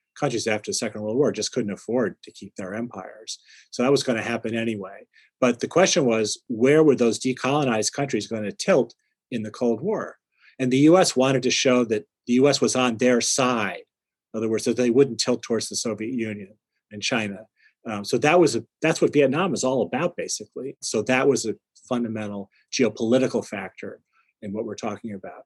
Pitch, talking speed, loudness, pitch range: 120 Hz, 205 wpm, -23 LUFS, 110-130 Hz